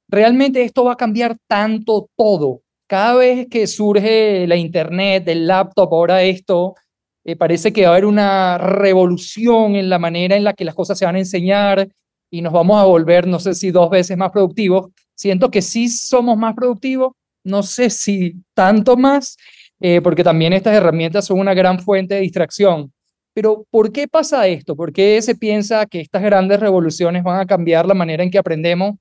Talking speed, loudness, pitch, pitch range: 190 wpm, -14 LUFS, 195 Hz, 180-215 Hz